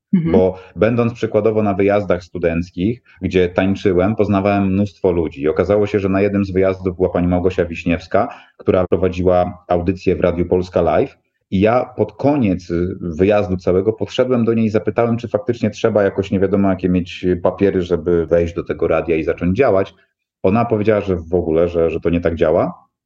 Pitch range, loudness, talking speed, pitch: 90-105 Hz, -17 LUFS, 175 wpm, 95 Hz